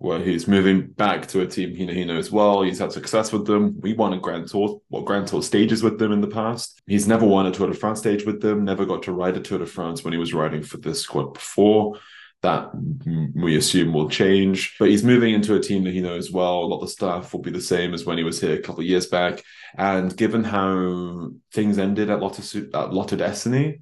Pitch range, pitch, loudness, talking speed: 90-105 Hz, 95 Hz, -22 LUFS, 255 wpm